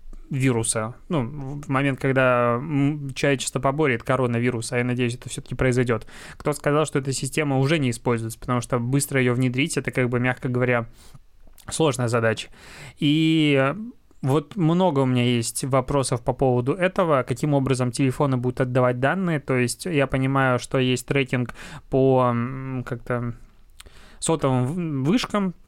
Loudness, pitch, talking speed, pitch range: -23 LUFS, 130 Hz, 145 wpm, 125-145 Hz